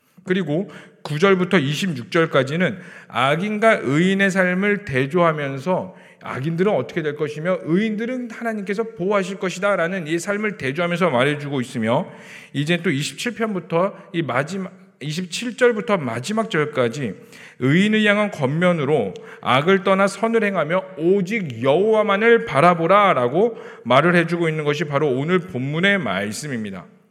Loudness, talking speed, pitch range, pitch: -20 LUFS, 305 characters per minute, 150-205 Hz, 185 Hz